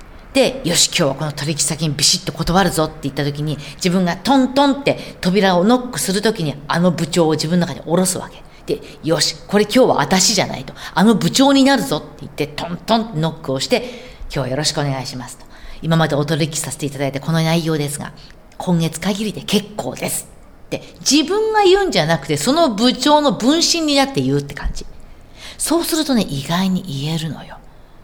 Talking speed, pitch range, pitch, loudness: 400 characters per minute, 150-225 Hz, 170 Hz, -17 LUFS